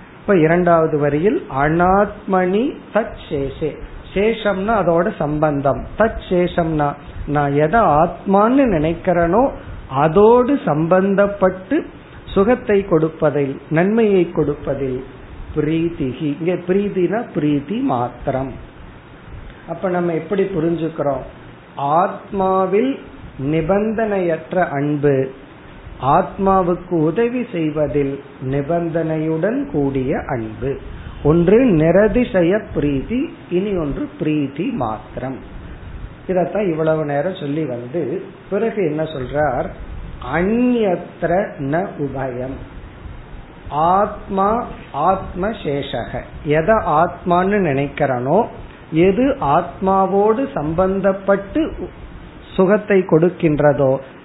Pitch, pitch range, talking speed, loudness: 165 Hz, 145-195 Hz, 65 wpm, -18 LUFS